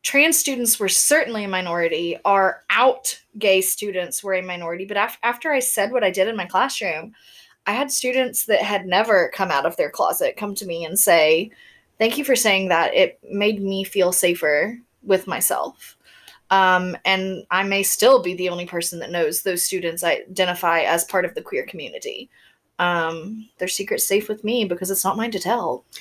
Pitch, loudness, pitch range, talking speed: 195 Hz, -20 LUFS, 180-230 Hz, 195 wpm